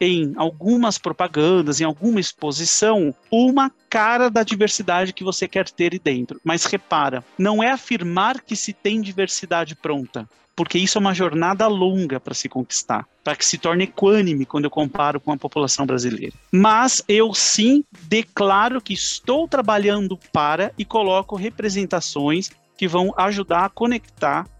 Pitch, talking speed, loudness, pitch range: 190 Hz, 155 wpm, -19 LUFS, 160-215 Hz